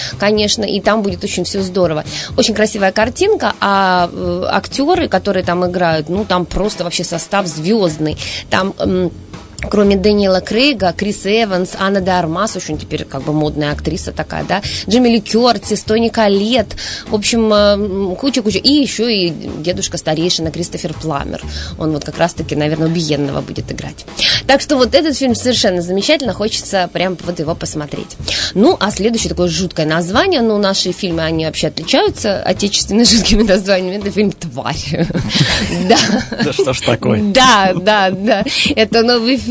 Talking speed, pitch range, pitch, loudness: 155 wpm, 175-220 Hz, 195 Hz, -14 LUFS